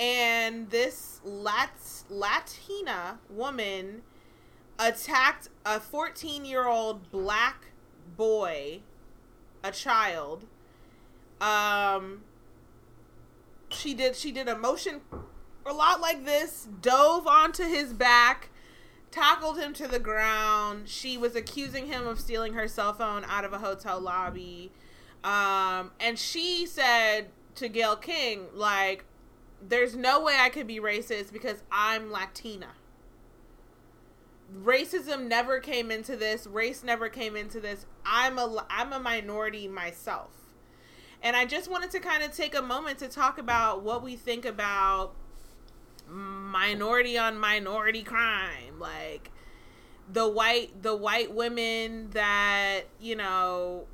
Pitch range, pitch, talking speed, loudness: 205-260 Hz, 225 Hz, 120 wpm, -28 LUFS